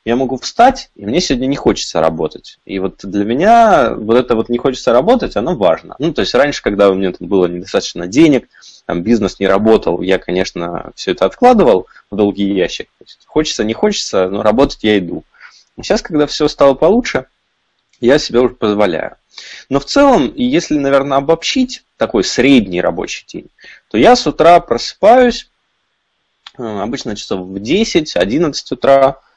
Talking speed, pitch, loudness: 170 wpm, 130 Hz, -13 LUFS